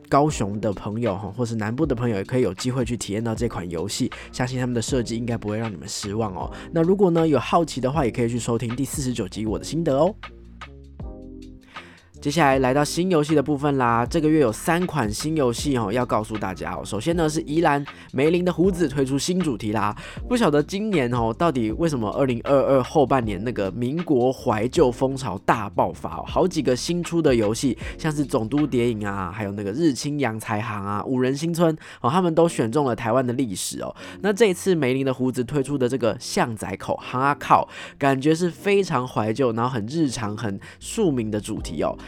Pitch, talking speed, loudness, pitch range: 125 Hz, 320 characters per minute, -23 LUFS, 110-155 Hz